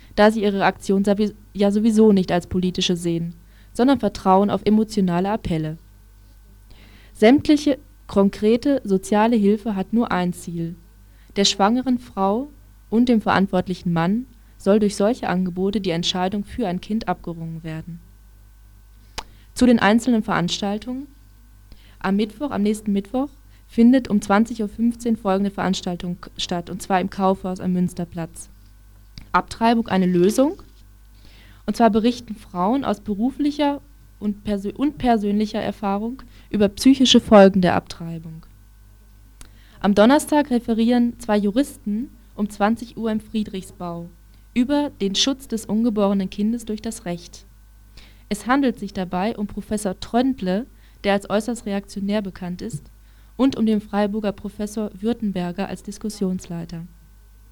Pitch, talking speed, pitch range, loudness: 200 Hz, 125 wpm, 175-225 Hz, -21 LUFS